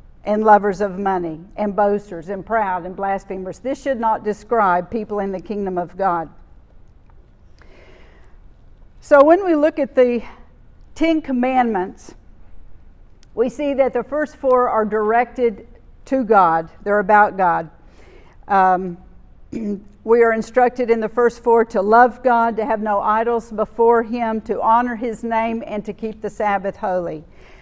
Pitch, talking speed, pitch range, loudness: 215 Hz, 150 wpm, 195-240 Hz, -18 LUFS